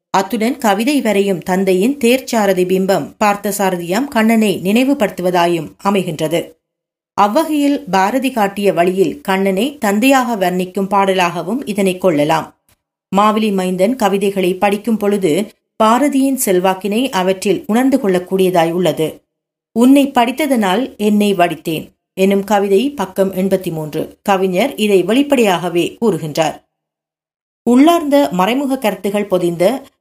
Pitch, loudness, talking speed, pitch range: 200 Hz, -14 LUFS, 95 wpm, 185-230 Hz